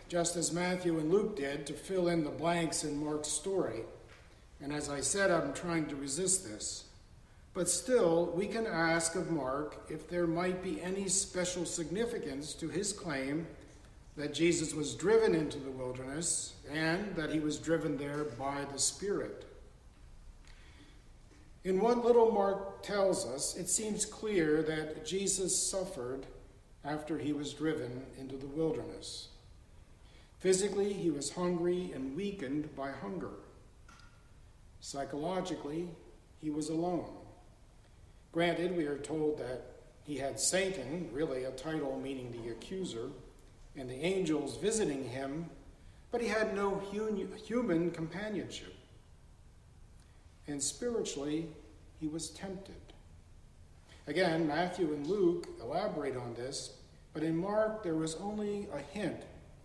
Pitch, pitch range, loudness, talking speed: 155 Hz, 135-185 Hz, -35 LUFS, 135 wpm